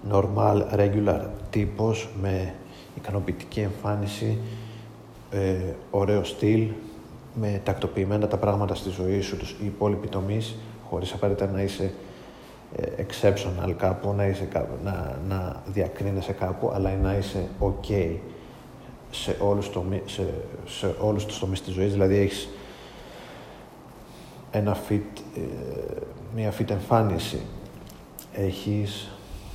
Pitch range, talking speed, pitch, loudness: 95-105 Hz, 115 wpm, 100 Hz, -27 LUFS